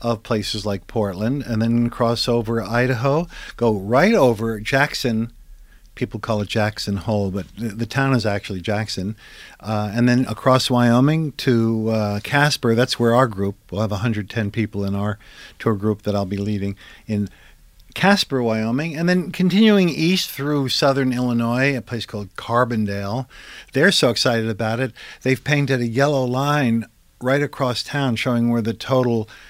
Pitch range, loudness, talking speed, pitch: 110-130 Hz, -20 LUFS, 160 wpm, 115 Hz